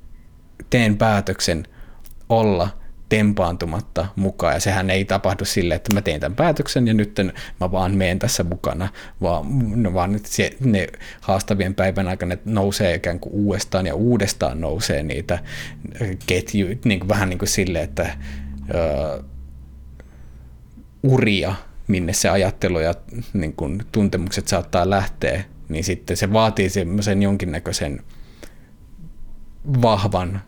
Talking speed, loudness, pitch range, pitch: 120 wpm, -21 LUFS, 85-105 Hz, 95 Hz